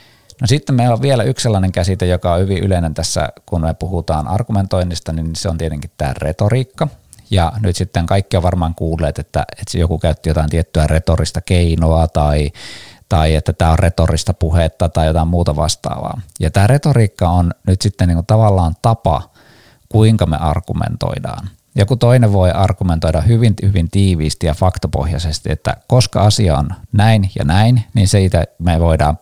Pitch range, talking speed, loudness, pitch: 80-105 Hz, 165 wpm, -15 LUFS, 90 Hz